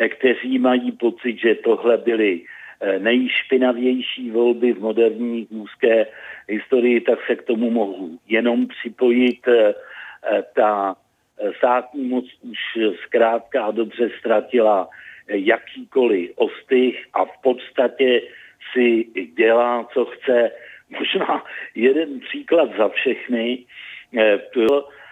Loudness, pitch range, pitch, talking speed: -19 LUFS, 115-125 Hz, 120 Hz, 100 wpm